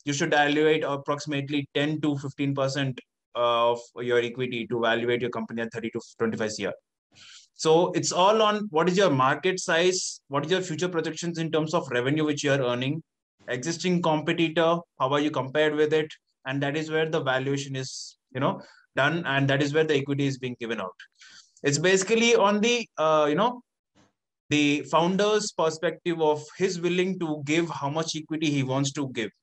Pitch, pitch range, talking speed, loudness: 150 Hz, 135-165 Hz, 190 wpm, -25 LUFS